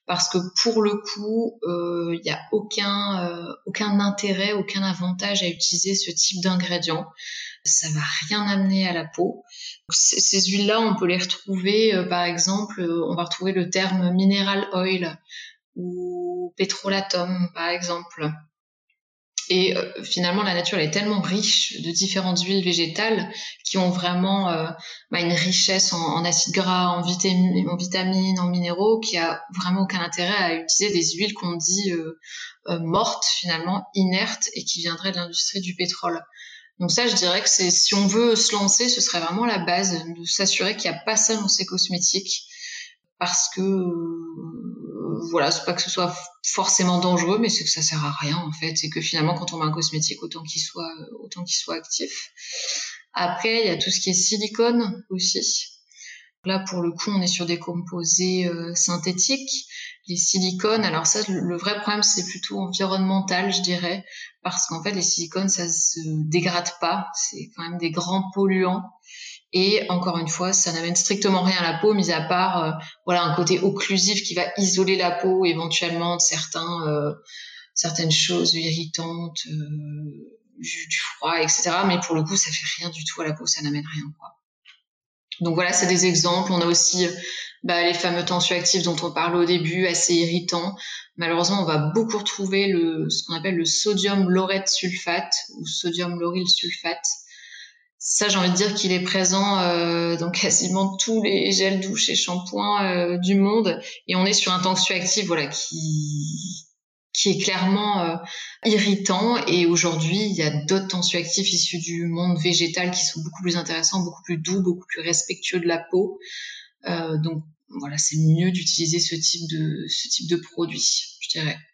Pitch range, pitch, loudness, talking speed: 170-195 Hz, 180 Hz, -22 LUFS, 180 wpm